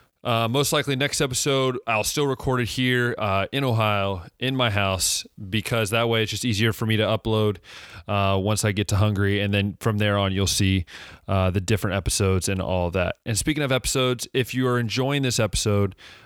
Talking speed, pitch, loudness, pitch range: 205 wpm, 110 Hz, -23 LUFS, 100-125 Hz